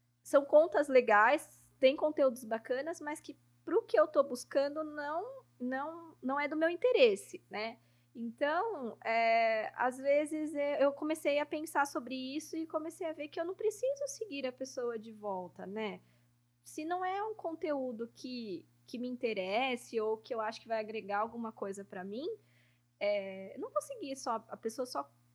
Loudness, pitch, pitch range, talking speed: -34 LUFS, 260 Hz, 220-310 Hz, 175 wpm